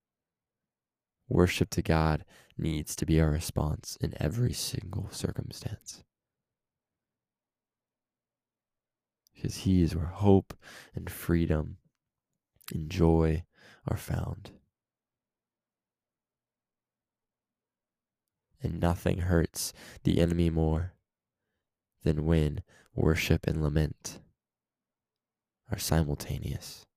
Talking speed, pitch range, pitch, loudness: 80 wpm, 80-90 Hz, 85 Hz, -30 LUFS